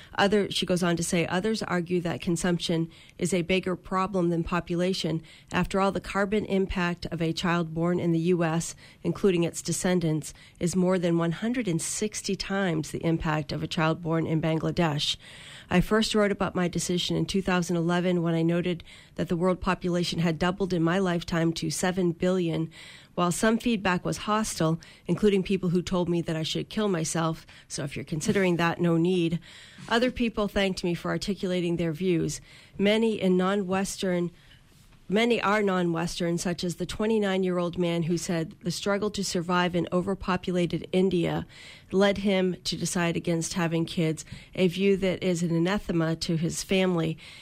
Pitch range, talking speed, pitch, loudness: 165-190 Hz, 170 wpm, 175 Hz, -27 LUFS